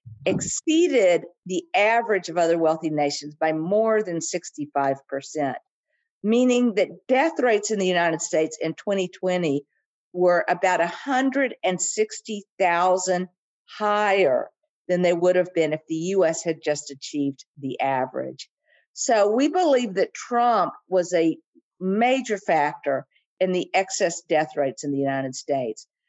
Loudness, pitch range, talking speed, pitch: -23 LUFS, 155-225 Hz, 130 wpm, 180 Hz